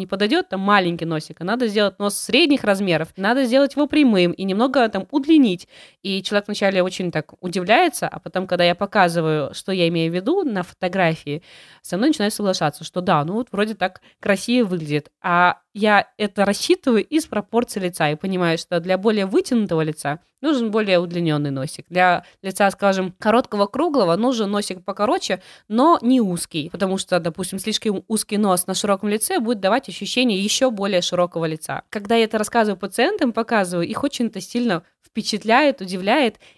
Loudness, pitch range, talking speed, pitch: -20 LUFS, 180-230 Hz, 170 wpm, 200 Hz